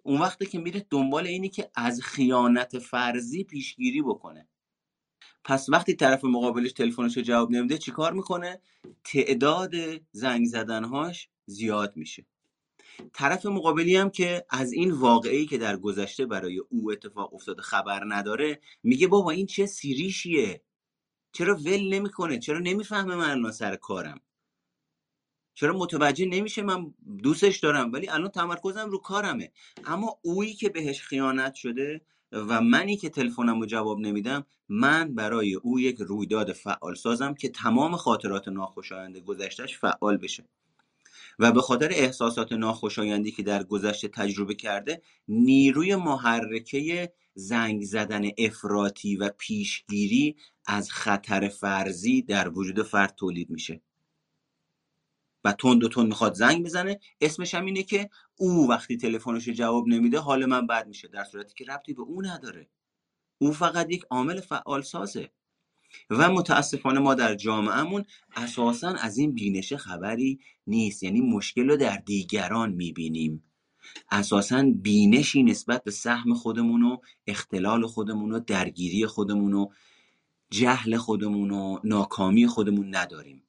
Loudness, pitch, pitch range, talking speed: -26 LUFS, 125 Hz, 105-175 Hz, 135 wpm